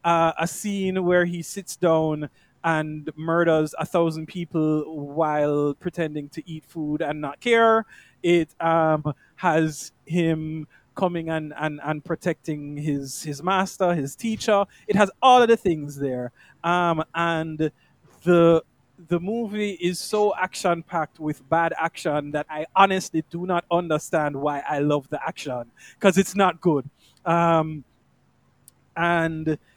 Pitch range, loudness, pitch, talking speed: 150-175 Hz, -23 LUFS, 160 Hz, 140 wpm